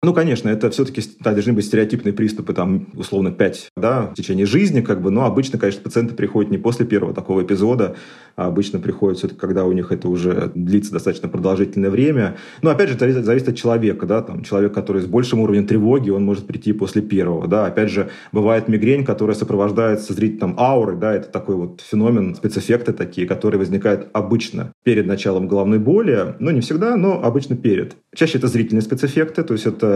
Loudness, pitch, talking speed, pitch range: -18 LUFS, 110 Hz, 195 wpm, 100-120 Hz